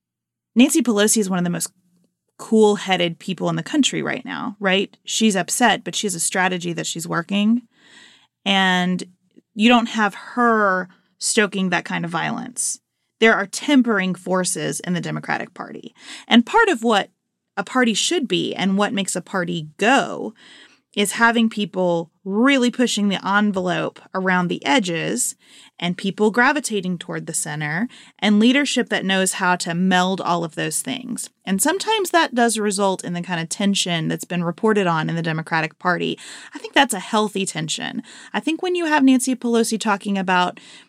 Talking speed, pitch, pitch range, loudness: 175 wpm, 200 Hz, 180-235 Hz, -20 LUFS